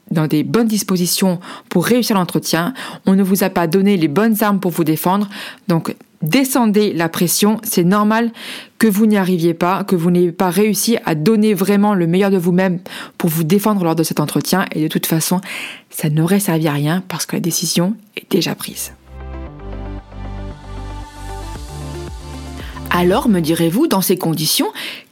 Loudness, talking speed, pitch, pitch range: -16 LUFS, 170 wpm, 180 Hz, 160-210 Hz